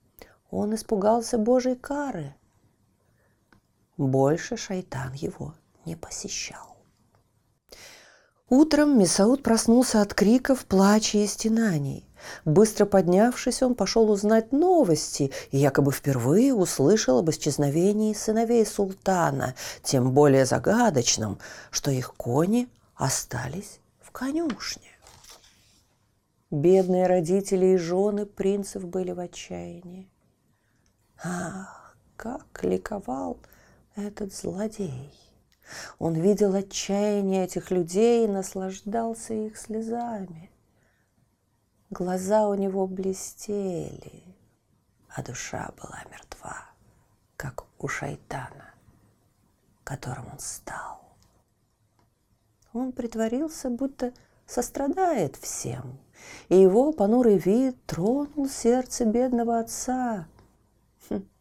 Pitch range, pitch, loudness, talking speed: 135-230 Hz, 195 Hz, -25 LUFS, 85 wpm